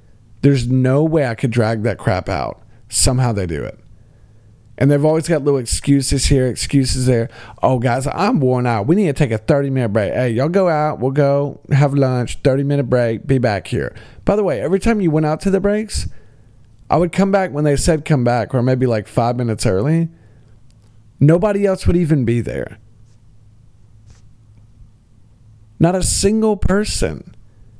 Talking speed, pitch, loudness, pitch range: 185 wpm, 125 Hz, -17 LUFS, 110-150 Hz